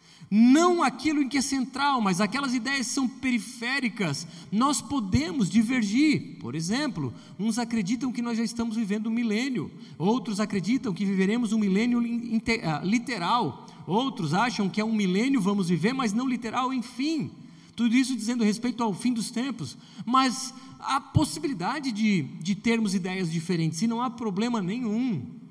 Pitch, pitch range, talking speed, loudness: 230 Hz, 200-255 Hz, 155 wpm, -26 LUFS